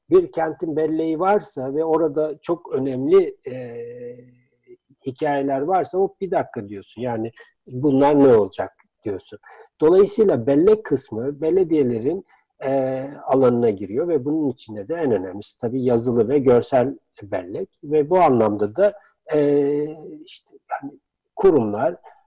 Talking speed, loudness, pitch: 125 wpm, -20 LUFS, 150 Hz